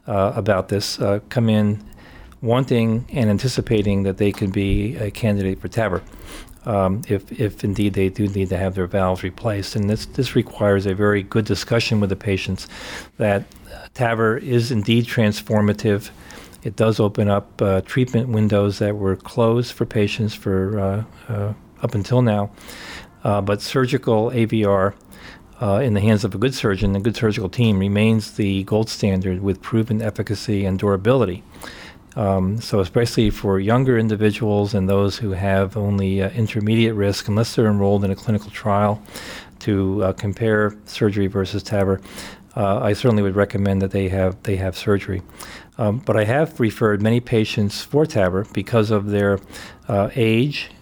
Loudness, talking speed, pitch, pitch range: -20 LUFS, 165 wpm, 105 Hz, 100-110 Hz